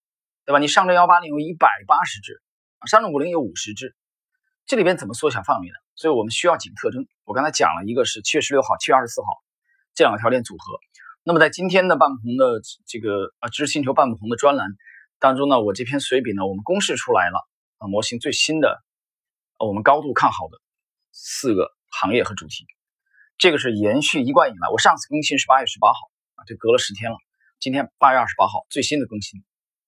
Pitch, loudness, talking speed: 150 Hz, -19 LUFS, 335 characters per minute